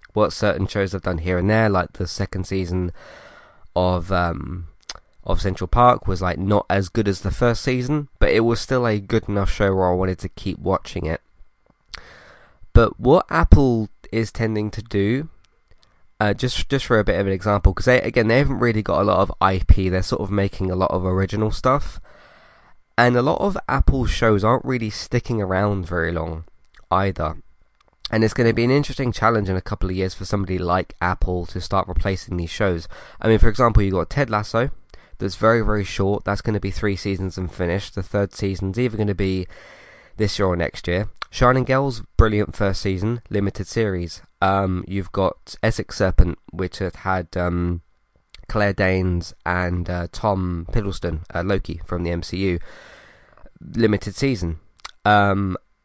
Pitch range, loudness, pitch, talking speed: 90-110 Hz, -21 LUFS, 95 Hz, 185 wpm